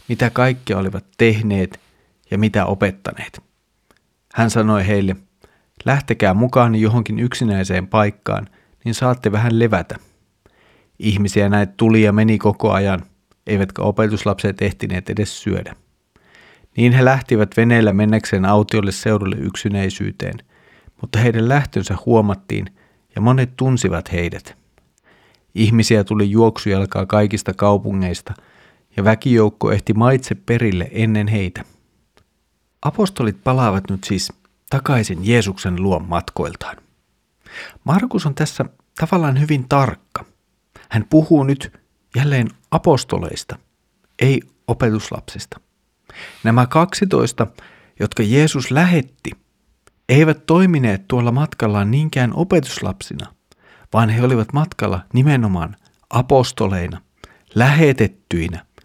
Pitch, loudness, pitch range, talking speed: 110 Hz, -17 LUFS, 100-125 Hz, 100 wpm